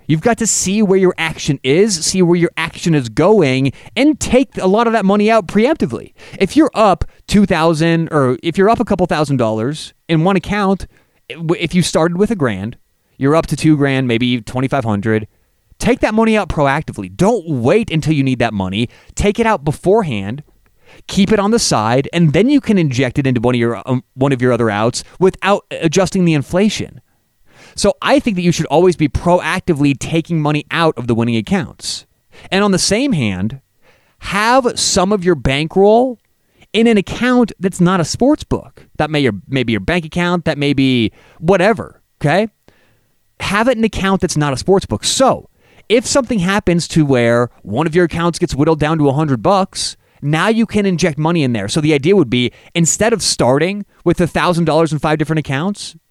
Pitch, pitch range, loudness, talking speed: 165 Hz, 135-195 Hz, -14 LUFS, 200 wpm